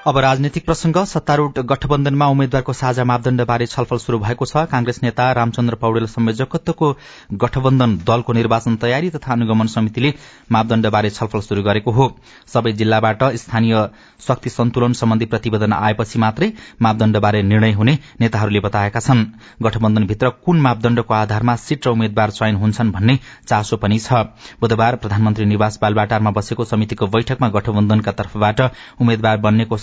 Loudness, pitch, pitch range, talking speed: -17 LUFS, 115 Hz, 110-130 Hz, 135 wpm